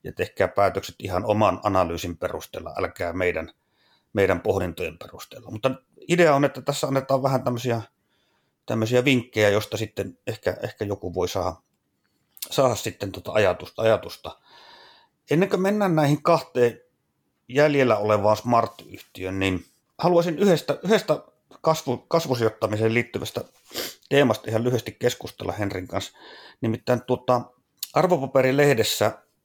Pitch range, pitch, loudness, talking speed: 105-145 Hz, 125 Hz, -24 LUFS, 120 wpm